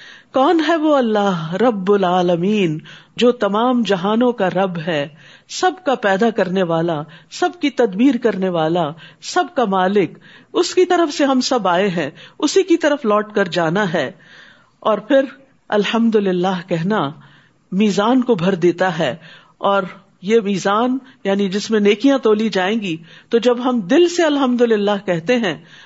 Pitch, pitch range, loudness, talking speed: 205 Hz, 180-250 Hz, -17 LUFS, 160 wpm